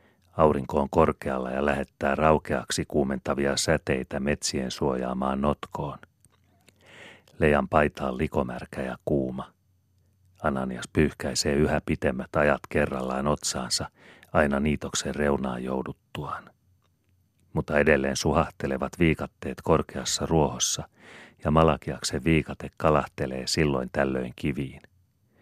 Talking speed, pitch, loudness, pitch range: 95 wpm, 75 Hz, -26 LUFS, 65-80 Hz